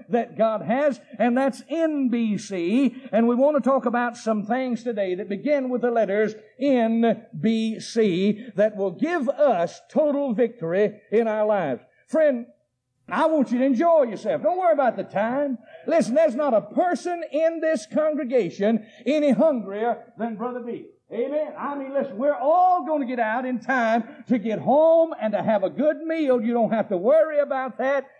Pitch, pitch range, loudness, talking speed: 250 Hz, 220-295 Hz, -23 LUFS, 175 wpm